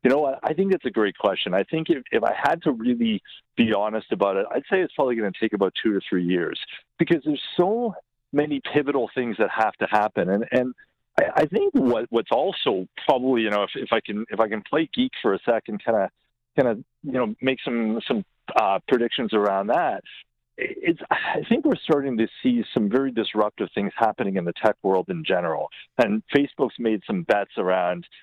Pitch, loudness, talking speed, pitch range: 130 Hz, -24 LUFS, 215 wpm, 110-175 Hz